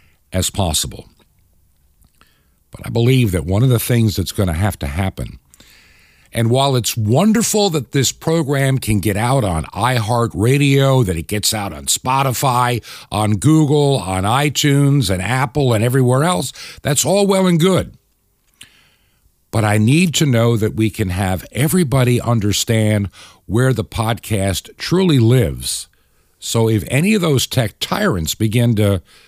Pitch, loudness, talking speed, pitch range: 115 Hz, -16 LUFS, 150 wpm, 95-135 Hz